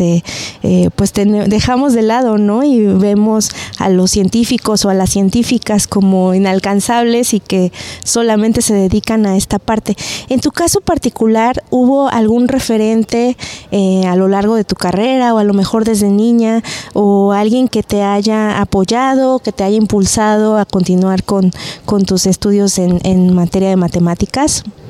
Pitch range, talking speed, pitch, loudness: 195-230 Hz, 165 wpm, 210 Hz, -12 LUFS